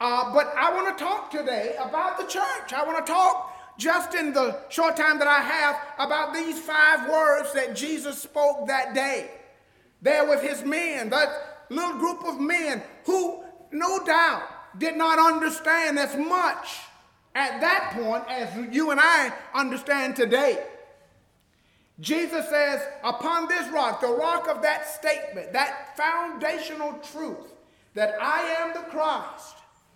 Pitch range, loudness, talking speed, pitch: 285-330 Hz, -24 LUFS, 150 wpm, 305 Hz